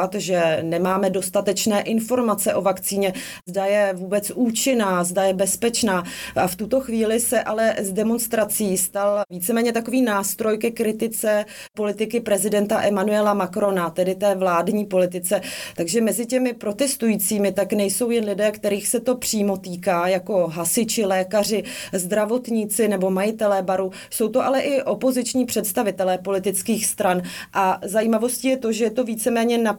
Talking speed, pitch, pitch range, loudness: 145 wpm, 210 Hz, 195-230 Hz, -21 LUFS